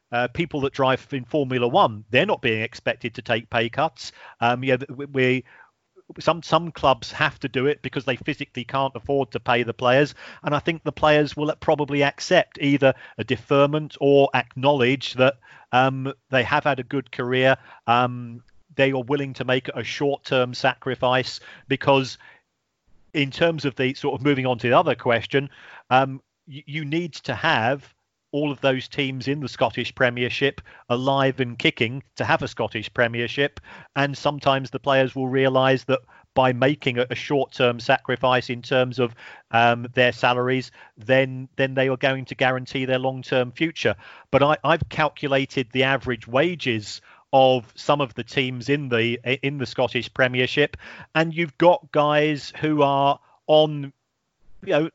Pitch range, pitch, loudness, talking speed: 125-140 Hz, 135 Hz, -22 LUFS, 170 wpm